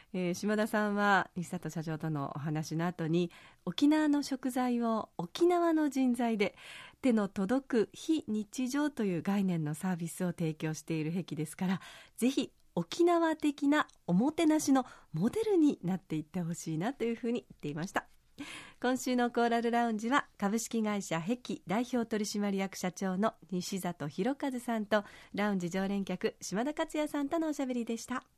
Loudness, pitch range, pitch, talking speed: -33 LUFS, 180-255 Hz, 215 Hz, 345 characters per minute